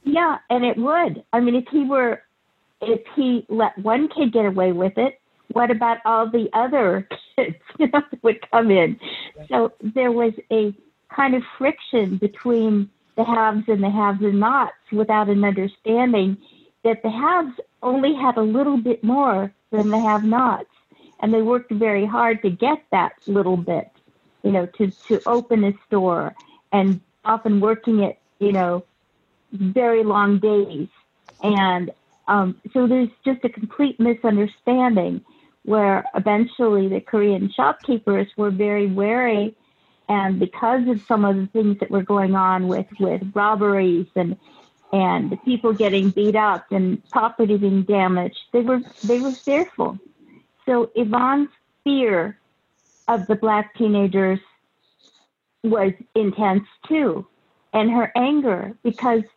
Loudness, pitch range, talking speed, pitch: -20 LUFS, 200-245 Hz, 150 wpm, 220 Hz